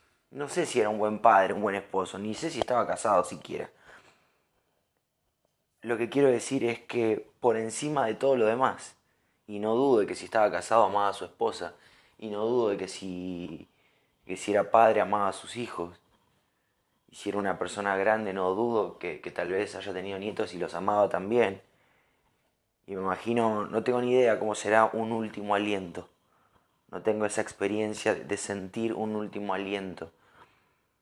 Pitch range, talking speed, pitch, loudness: 95-110 Hz, 180 wpm, 105 Hz, -28 LUFS